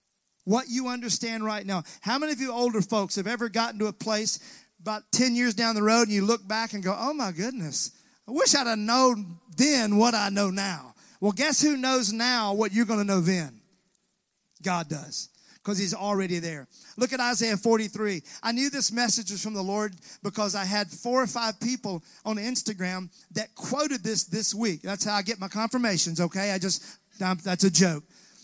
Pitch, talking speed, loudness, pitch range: 215 Hz, 205 wpm, -26 LUFS, 195-235 Hz